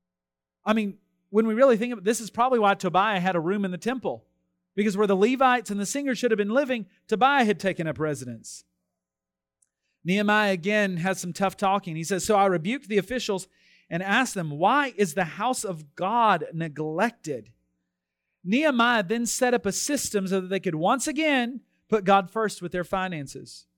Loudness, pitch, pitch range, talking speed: -25 LUFS, 195 Hz, 170-225 Hz, 190 wpm